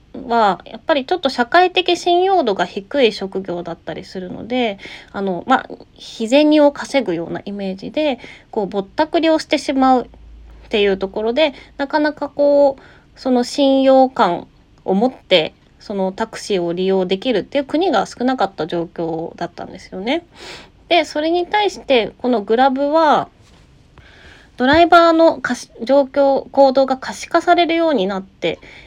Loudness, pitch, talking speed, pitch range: -17 LUFS, 265 Hz, 320 characters per minute, 200-305 Hz